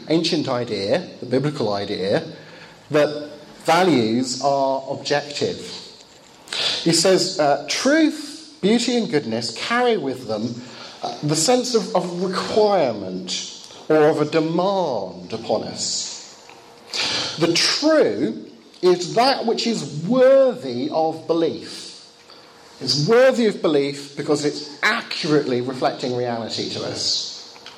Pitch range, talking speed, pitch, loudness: 135-205 Hz, 110 wpm, 155 Hz, -20 LUFS